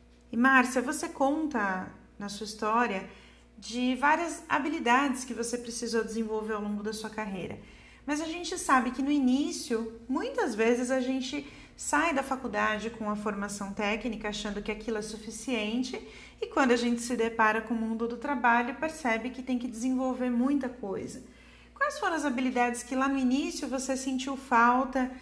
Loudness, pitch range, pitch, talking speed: -29 LUFS, 225-270 Hz, 245 Hz, 170 wpm